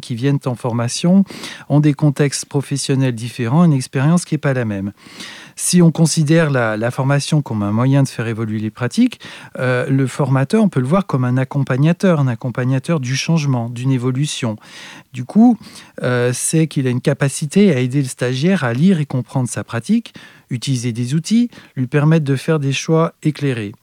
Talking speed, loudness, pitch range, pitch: 185 wpm, -17 LUFS, 125-160 Hz, 140 Hz